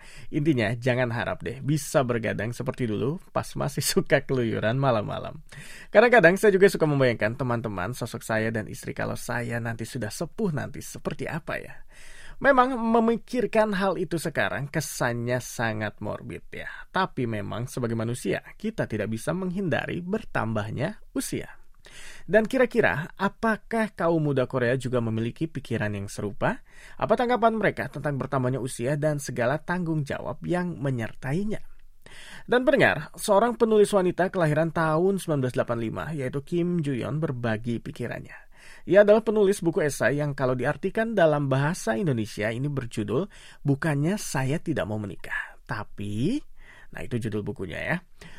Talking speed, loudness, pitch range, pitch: 140 wpm, -26 LUFS, 120-185 Hz, 145 Hz